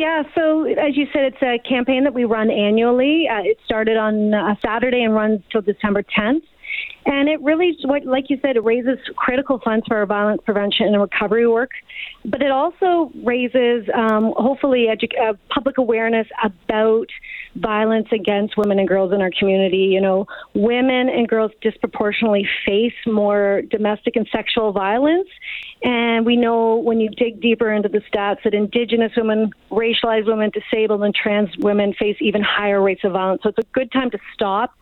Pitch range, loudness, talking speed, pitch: 210-260 Hz, -18 LUFS, 180 wpm, 225 Hz